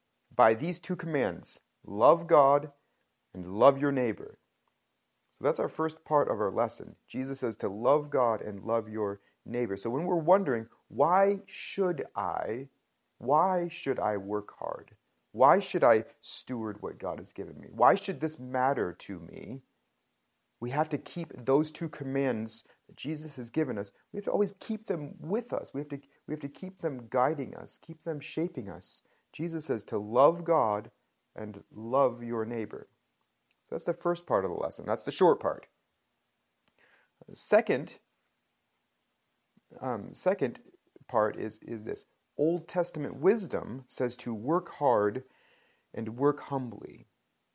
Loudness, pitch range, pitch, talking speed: -30 LUFS, 115-165 Hz, 140 Hz, 160 wpm